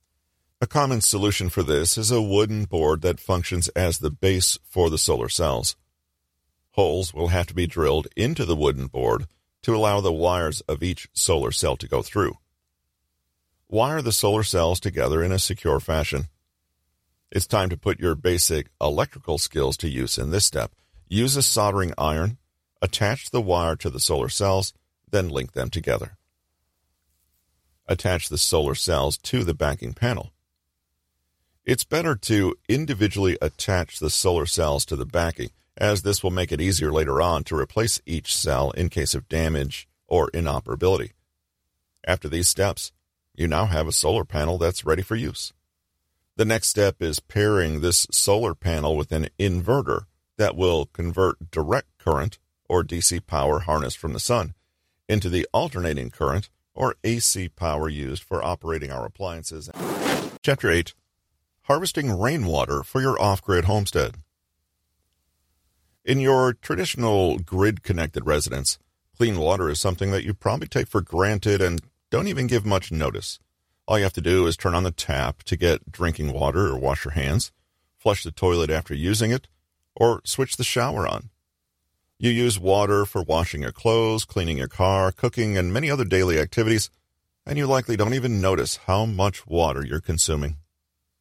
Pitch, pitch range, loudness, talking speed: 85 Hz, 75-100 Hz, -23 LUFS, 165 wpm